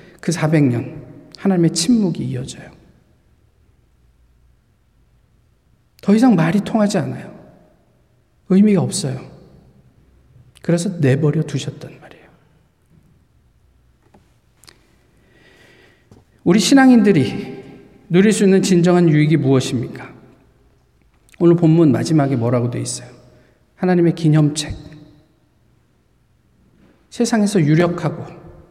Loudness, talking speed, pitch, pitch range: -16 LUFS, 205 characters per minute, 160 Hz, 140-185 Hz